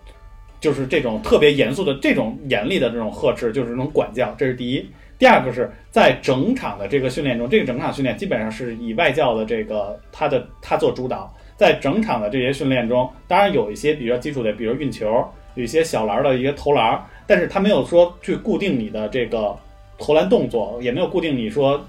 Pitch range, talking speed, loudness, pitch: 110-145 Hz, 330 characters per minute, -19 LUFS, 125 Hz